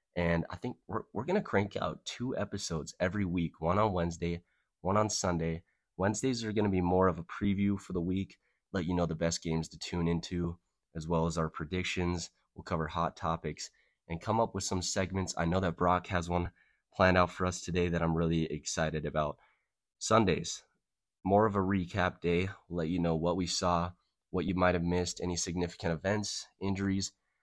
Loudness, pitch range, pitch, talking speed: -33 LUFS, 85-95 Hz, 90 Hz, 200 wpm